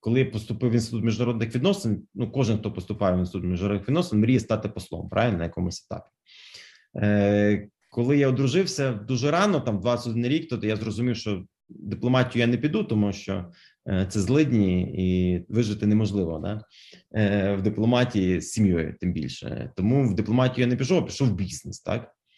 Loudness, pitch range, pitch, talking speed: -25 LUFS, 100-125 Hz, 110 Hz, 175 wpm